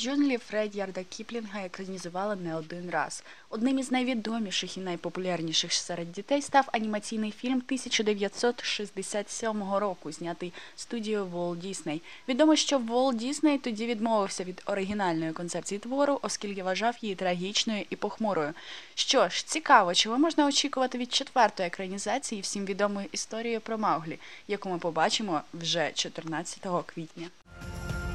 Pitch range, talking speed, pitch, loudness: 180-235 Hz, 130 wpm, 205 Hz, -29 LUFS